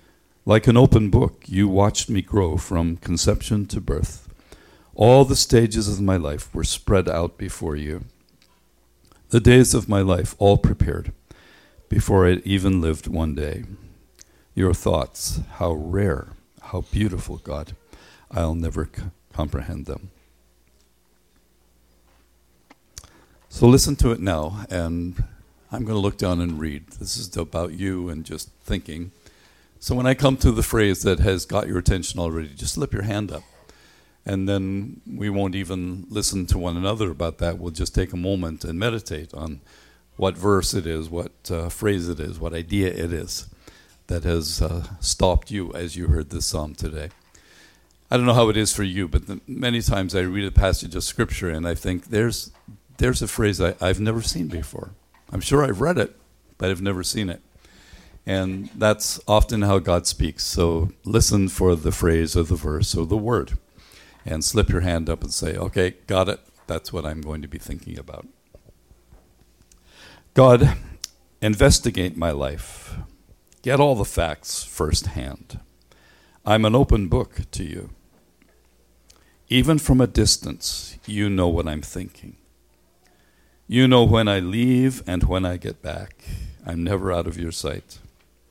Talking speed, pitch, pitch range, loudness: 165 wpm, 90 Hz, 80-105 Hz, -22 LUFS